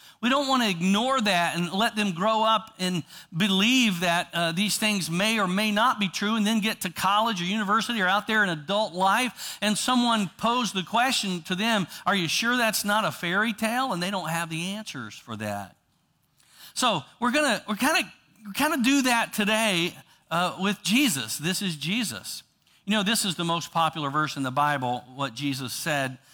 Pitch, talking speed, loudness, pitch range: 200 Hz, 205 wpm, -25 LUFS, 170-220 Hz